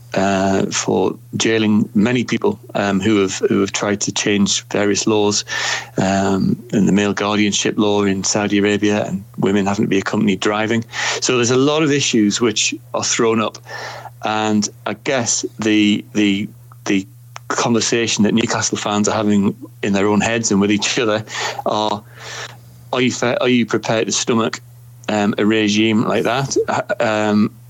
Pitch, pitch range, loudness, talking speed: 105 Hz, 105-115 Hz, -17 LUFS, 165 wpm